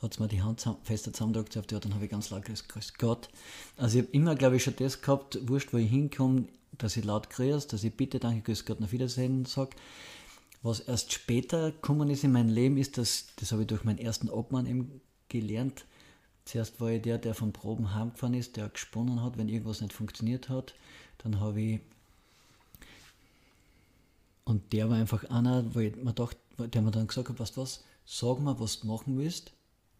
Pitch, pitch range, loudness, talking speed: 115 Hz, 110-130 Hz, -32 LUFS, 205 wpm